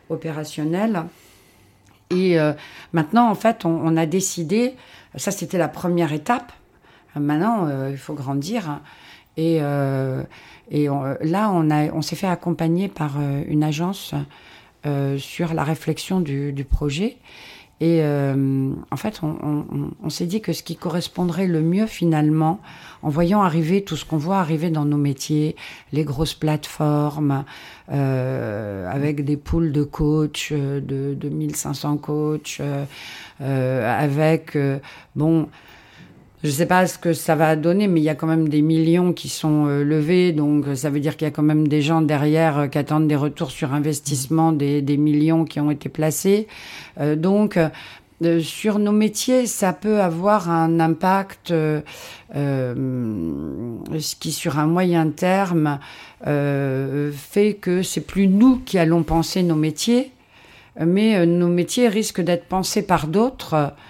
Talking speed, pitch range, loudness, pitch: 160 wpm, 145-175 Hz, -21 LUFS, 155 Hz